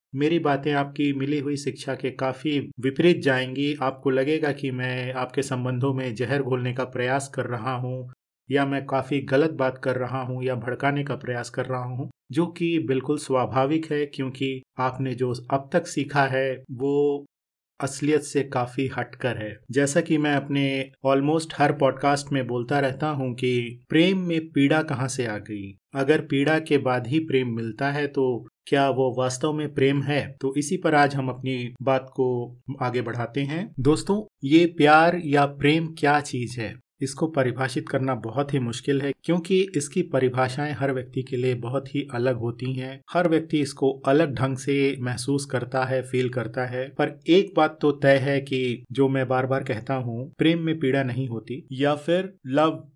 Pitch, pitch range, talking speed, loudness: 135 Hz, 130-145 Hz, 185 wpm, -24 LUFS